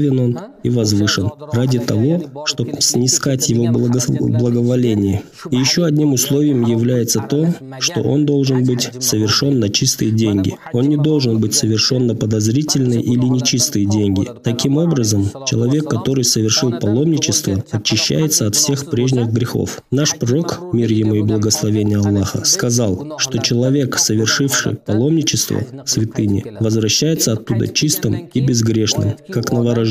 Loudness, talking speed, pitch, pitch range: -16 LUFS, 130 wpm, 120 Hz, 110-140 Hz